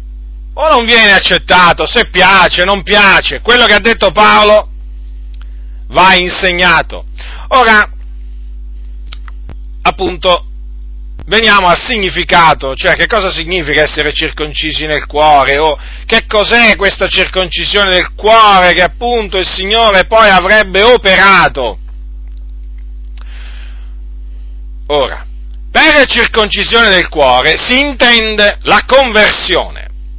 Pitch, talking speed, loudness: 175 Hz, 100 wpm, -7 LUFS